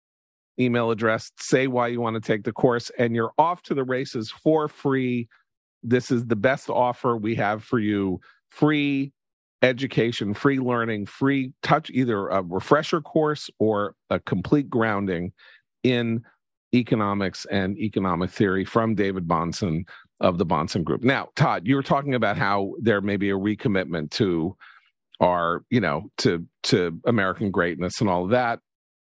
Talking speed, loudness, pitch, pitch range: 155 wpm, -24 LUFS, 115 Hz, 100-130 Hz